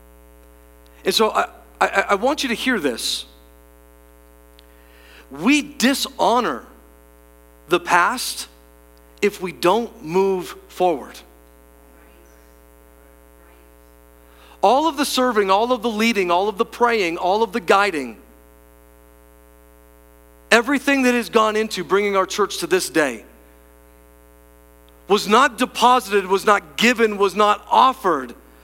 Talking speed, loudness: 115 wpm, -19 LUFS